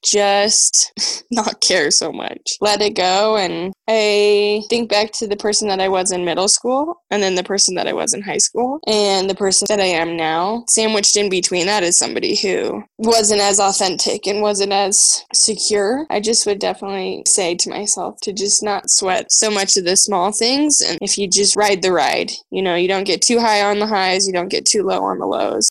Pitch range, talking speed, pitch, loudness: 190-210 Hz, 220 wpm, 200 Hz, -15 LUFS